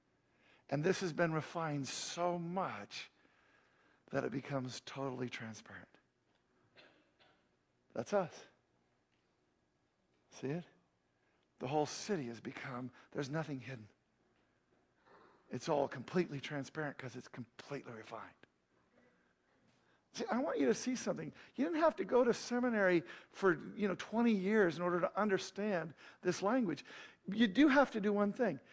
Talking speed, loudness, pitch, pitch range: 135 wpm, -37 LUFS, 160 Hz, 130-200 Hz